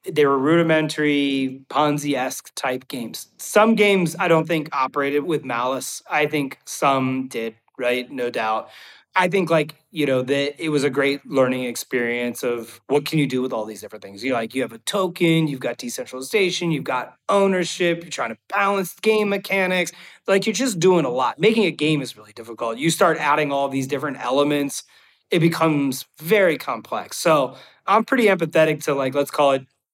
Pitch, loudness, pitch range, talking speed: 150 Hz, -21 LUFS, 135-170 Hz, 190 wpm